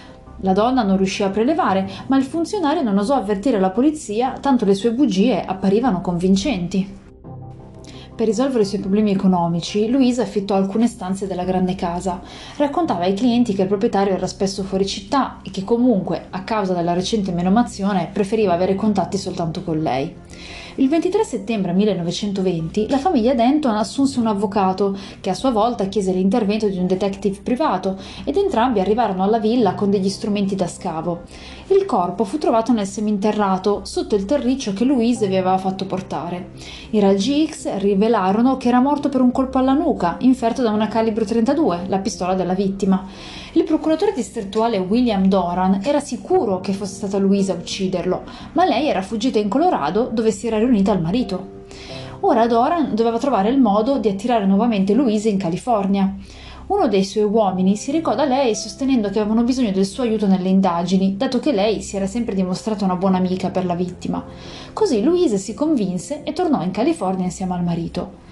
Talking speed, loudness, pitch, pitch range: 175 wpm, -19 LUFS, 210 Hz, 190-245 Hz